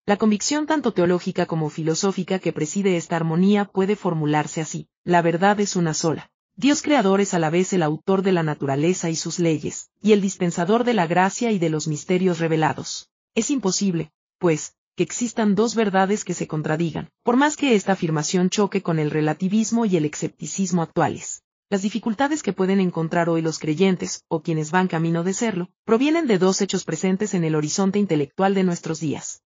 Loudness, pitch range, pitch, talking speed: -22 LUFS, 165-205 Hz, 185 Hz, 185 wpm